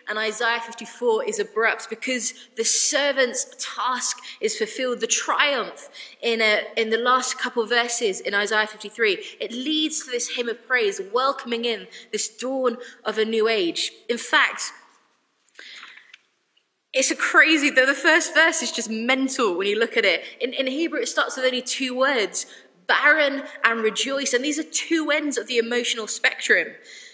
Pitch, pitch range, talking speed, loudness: 255 Hz, 230-300 Hz, 175 wpm, -22 LUFS